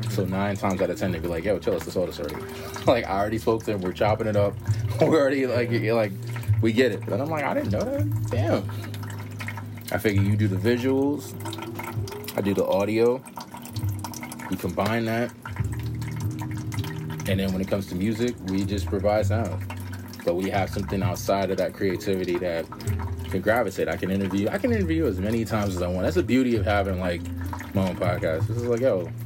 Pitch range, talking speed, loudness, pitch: 95-115 Hz, 205 wpm, -26 LUFS, 105 Hz